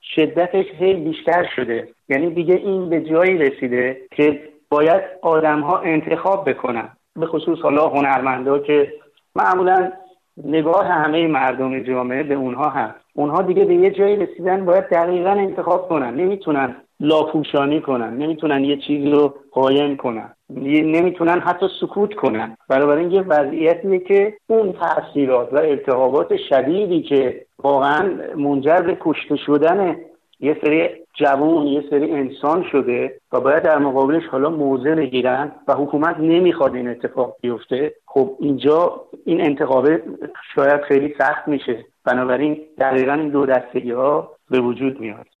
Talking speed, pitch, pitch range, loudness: 135 wpm, 150 Hz, 135-175 Hz, -18 LUFS